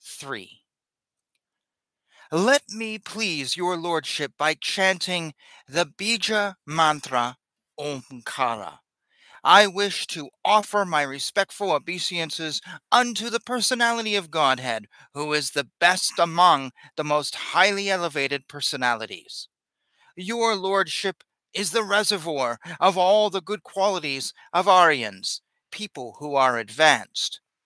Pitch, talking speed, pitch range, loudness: 175 Hz, 110 wpm, 145-205 Hz, -23 LUFS